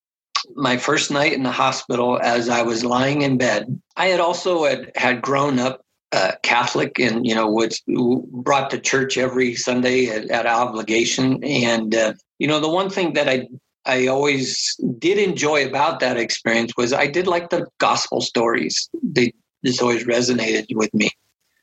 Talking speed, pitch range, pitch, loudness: 170 wpm, 120-145 Hz, 130 Hz, -19 LUFS